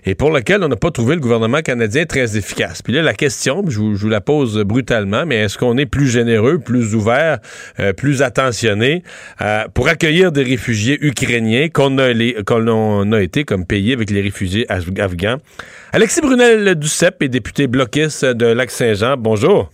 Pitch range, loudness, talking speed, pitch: 110-145 Hz, -15 LUFS, 185 wpm, 125 Hz